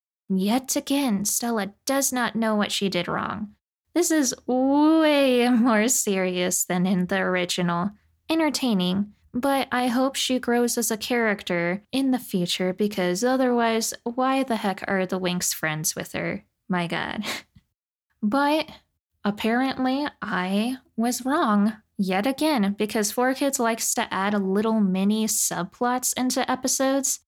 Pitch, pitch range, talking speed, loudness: 225 Hz, 195-260 Hz, 140 wpm, -24 LUFS